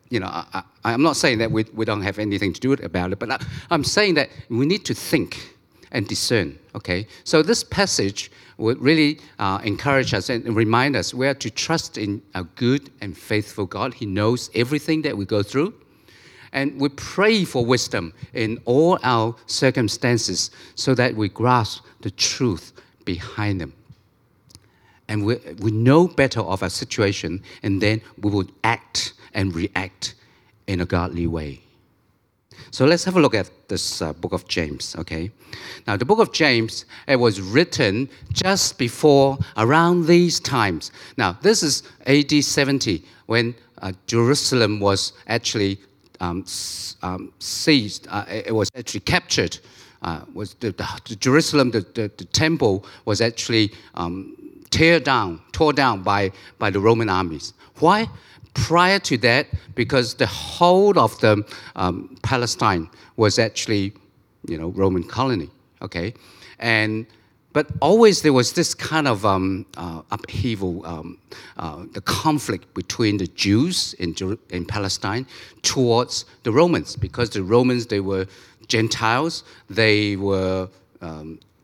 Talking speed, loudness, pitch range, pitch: 155 wpm, -21 LUFS, 100-130 Hz, 115 Hz